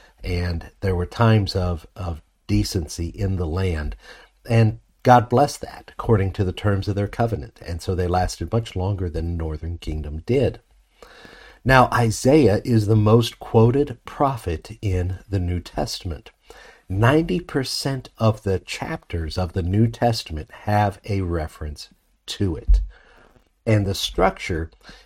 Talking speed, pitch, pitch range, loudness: 140 wpm, 100 Hz, 90-115 Hz, -22 LUFS